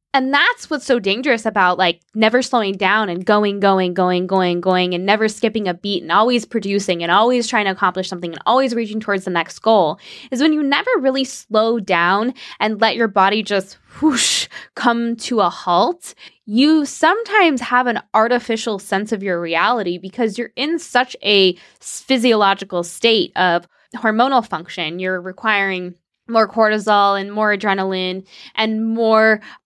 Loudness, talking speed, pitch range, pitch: -17 LUFS, 165 wpm, 190-240 Hz, 215 Hz